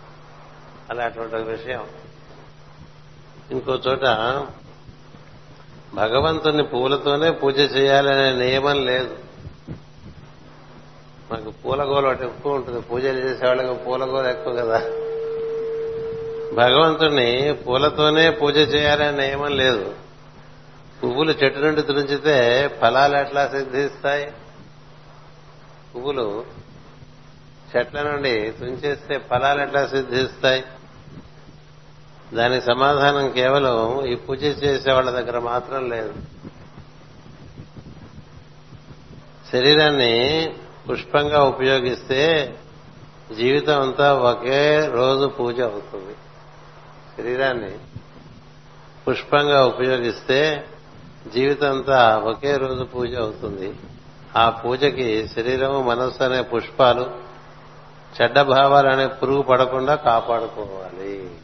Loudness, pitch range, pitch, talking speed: -19 LUFS, 125-145 Hz, 135 Hz, 75 wpm